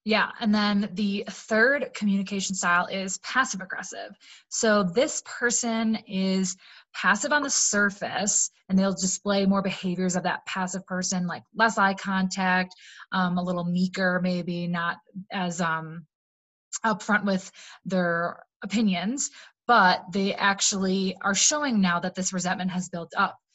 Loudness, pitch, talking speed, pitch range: -25 LUFS, 190 Hz, 140 wpm, 180-210 Hz